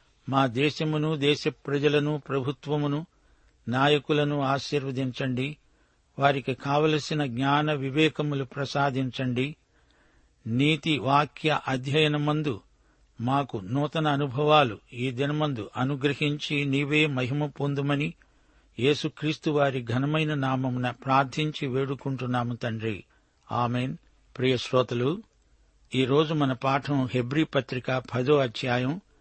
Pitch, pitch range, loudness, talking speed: 140 Hz, 130-150 Hz, -27 LUFS, 85 wpm